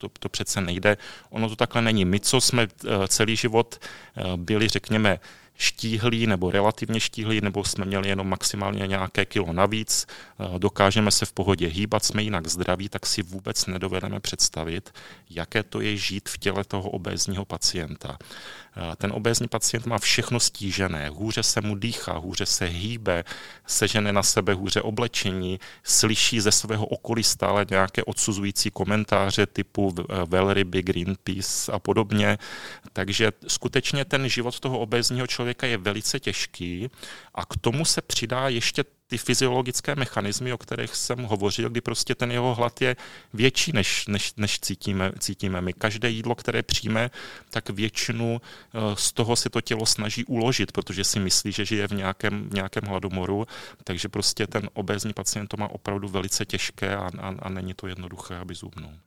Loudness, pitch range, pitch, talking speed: -25 LUFS, 95-115 Hz, 105 Hz, 160 wpm